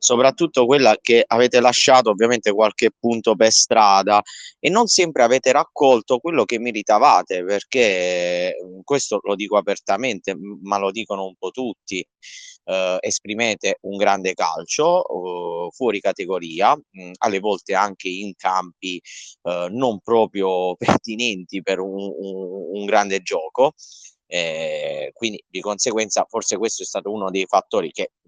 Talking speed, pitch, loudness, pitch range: 140 wpm, 105 Hz, -19 LUFS, 95-140 Hz